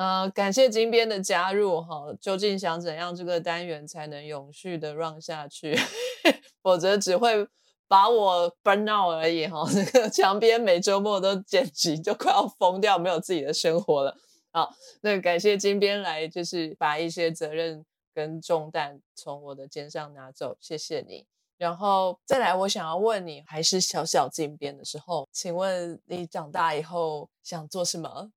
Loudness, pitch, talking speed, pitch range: -25 LUFS, 175 Hz, 260 characters per minute, 160-205 Hz